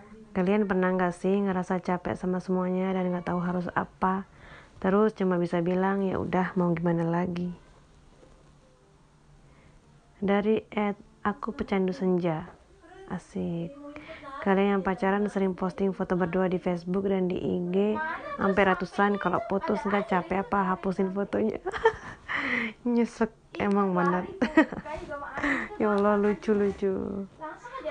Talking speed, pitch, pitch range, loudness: 125 wpm, 195 Hz, 185-210 Hz, -28 LUFS